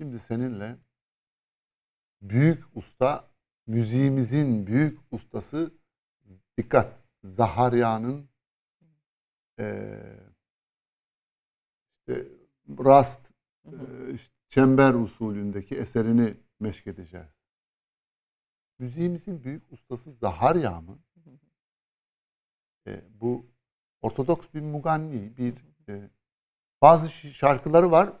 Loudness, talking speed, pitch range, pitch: -24 LUFS, 70 wpm, 110-150 Hz, 125 Hz